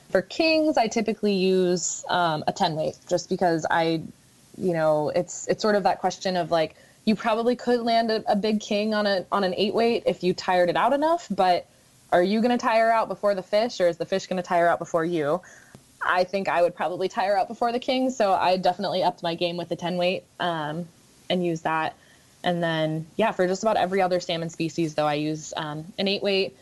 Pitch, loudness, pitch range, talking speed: 185 Hz, -24 LUFS, 170-210 Hz, 230 wpm